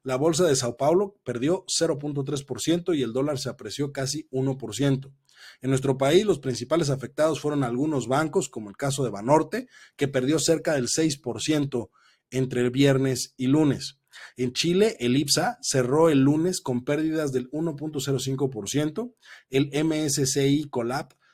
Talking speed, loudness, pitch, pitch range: 145 wpm, -25 LUFS, 140 Hz, 130-155 Hz